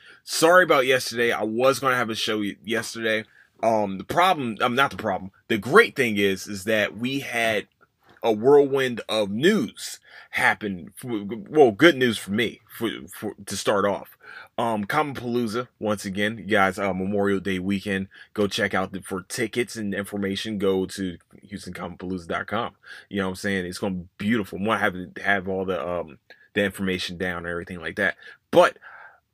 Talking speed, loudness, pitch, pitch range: 185 wpm, -24 LUFS, 105 Hz, 95-115 Hz